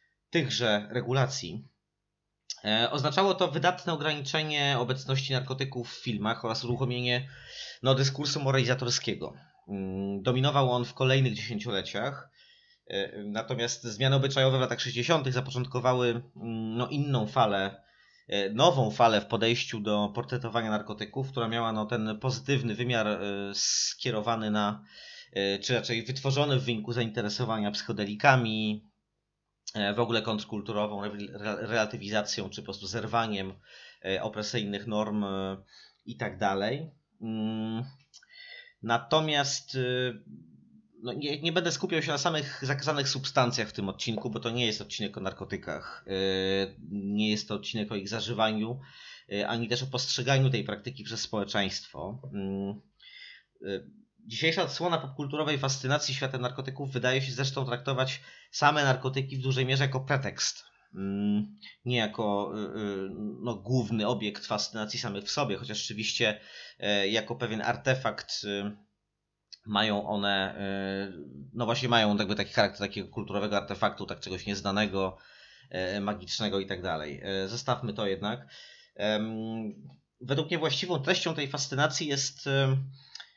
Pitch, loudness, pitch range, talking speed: 115 Hz, -30 LUFS, 105-135 Hz, 115 wpm